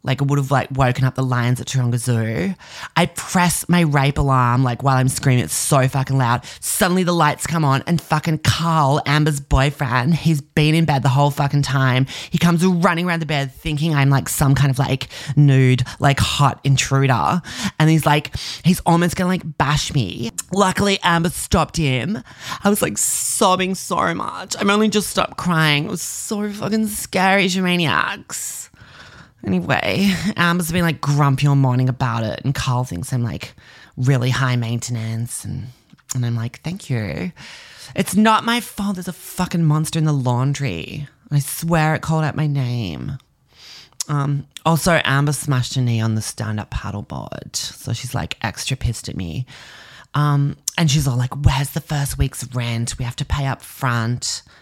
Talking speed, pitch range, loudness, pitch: 180 wpm, 130-165 Hz, -19 LUFS, 140 Hz